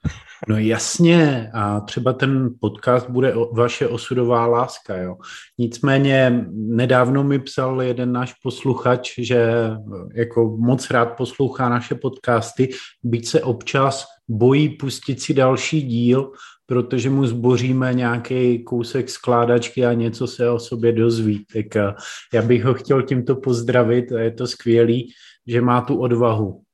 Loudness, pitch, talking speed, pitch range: -19 LUFS, 125 Hz, 135 wpm, 115-130 Hz